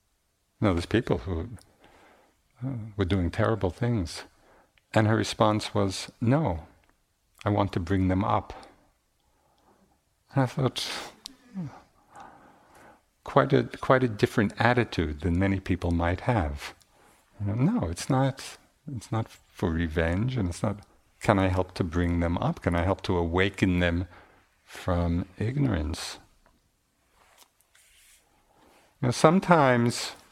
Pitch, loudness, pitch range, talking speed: 100 Hz, -27 LUFS, 90-115 Hz, 130 wpm